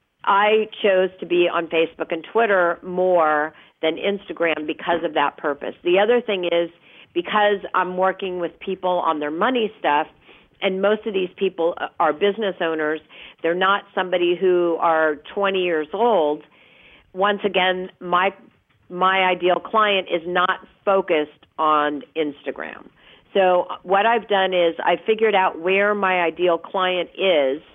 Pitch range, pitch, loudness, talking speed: 165-195 Hz, 180 Hz, -20 LUFS, 145 wpm